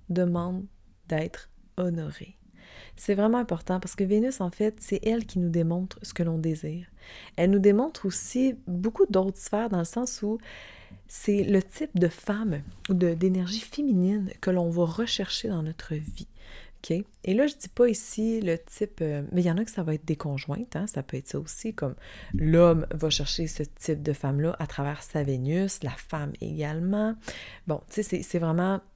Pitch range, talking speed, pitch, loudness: 160-210 Hz, 195 wpm, 180 Hz, -28 LUFS